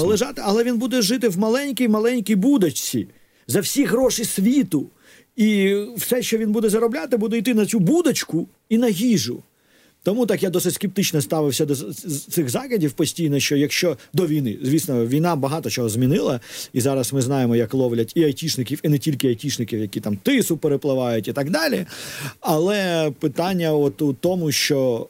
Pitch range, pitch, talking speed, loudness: 140-225 Hz, 170 Hz, 165 wpm, -21 LUFS